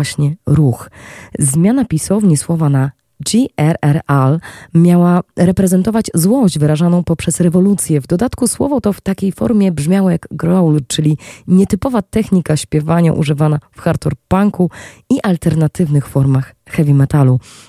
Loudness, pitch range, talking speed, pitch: -14 LUFS, 150-190 Hz, 120 wpm, 165 Hz